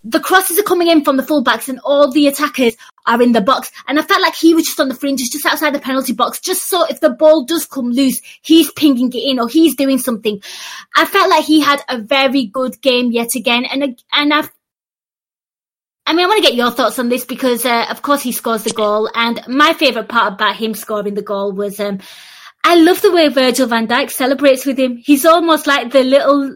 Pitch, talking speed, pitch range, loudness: 270 Hz, 235 wpm, 240-305 Hz, -13 LUFS